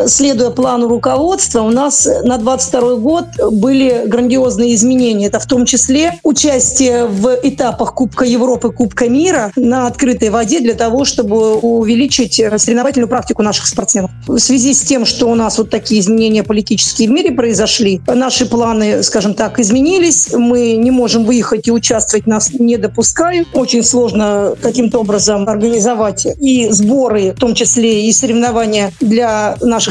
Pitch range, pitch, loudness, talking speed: 225-255 Hz, 240 Hz, -11 LUFS, 150 wpm